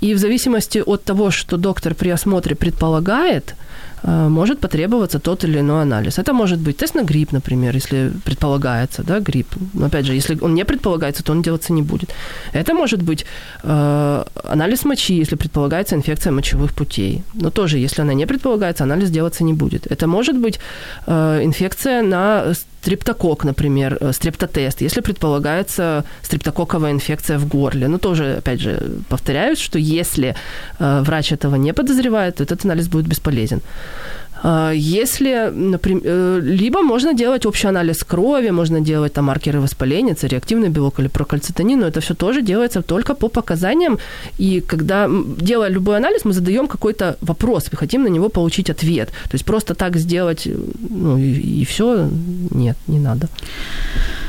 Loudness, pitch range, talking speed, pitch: -17 LUFS, 150-200 Hz, 160 wpm, 165 Hz